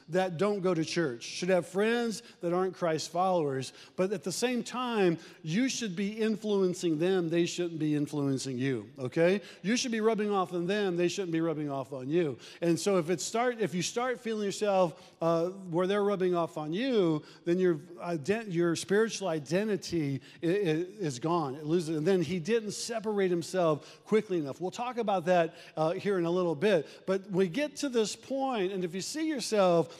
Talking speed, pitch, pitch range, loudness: 195 wpm, 180 Hz, 165-205 Hz, -31 LUFS